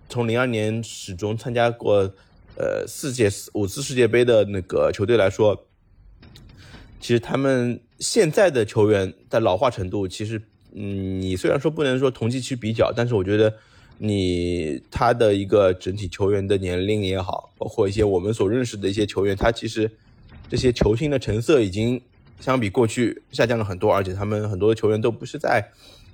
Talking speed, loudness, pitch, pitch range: 275 characters per minute, -22 LUFS, 105 Hz, 100-120 Hz